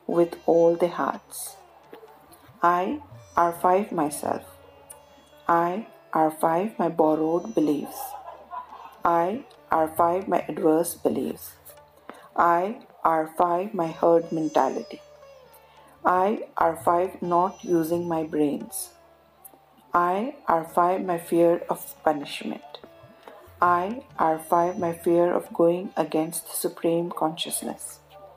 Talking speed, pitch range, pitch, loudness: 110 wpm, 165-180 Hz, 170 Hz, -25 LUFS